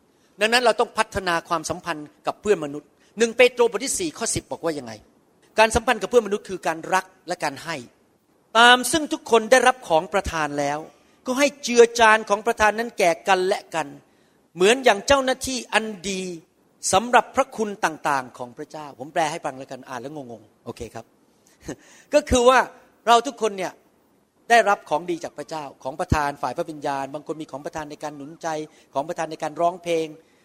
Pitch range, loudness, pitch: 150-230 Hz, -21 LUFS, 180 Hz